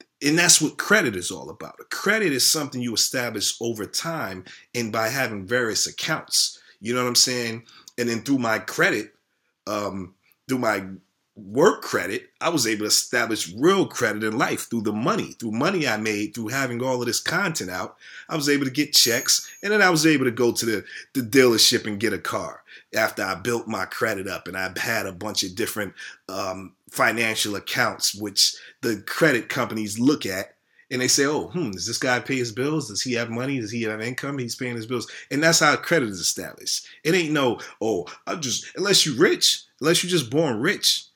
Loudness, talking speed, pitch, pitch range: -22 LUFS, 210 wpm, 120 Hz, 110-135 Hz